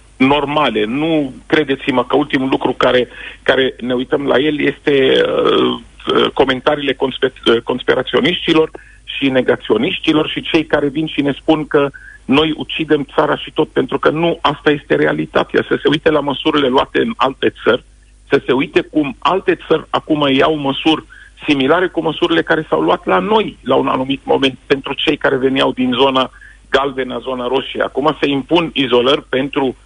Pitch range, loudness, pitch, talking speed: 130-155 Hz, -15 LUFS, 145 Hz, 170 wpm